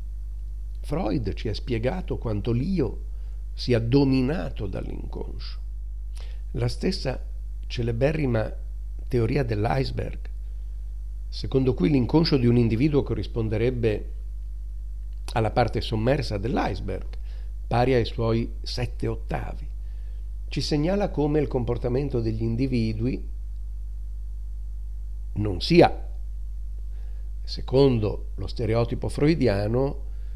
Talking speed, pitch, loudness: 85 wpm, 105 Hz, -25 LUFS